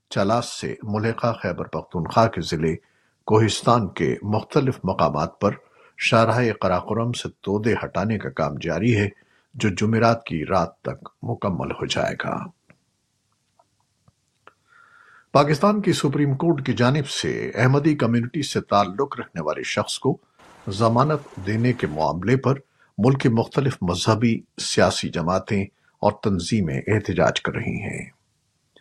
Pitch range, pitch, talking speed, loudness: 100-130 Hz, 115 Hz, 130 wpm, -22 LUFS